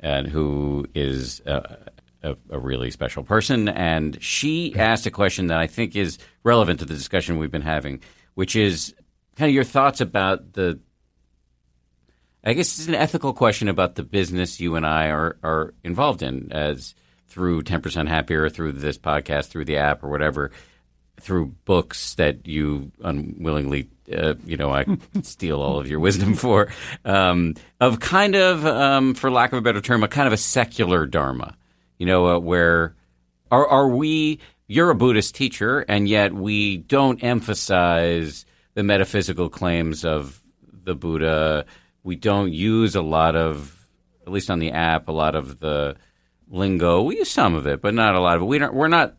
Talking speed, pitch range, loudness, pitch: 180 wpm, 75-105 Hz, -21 LUFS, 85 Hz